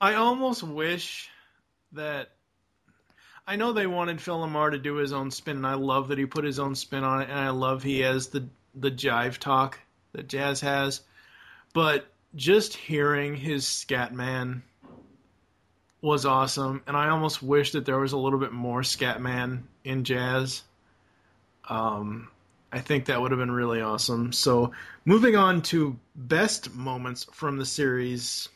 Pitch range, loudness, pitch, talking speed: 125-145 Hz, -27 LUFS, 135 Hz, 160 wpm